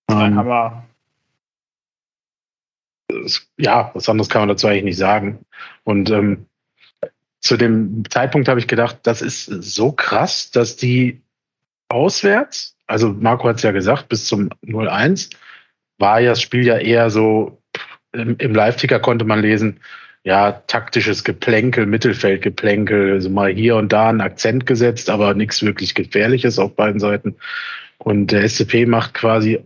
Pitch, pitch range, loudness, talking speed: 110 Hz, 105-120 Hz, -16 LUFS, 145 wpm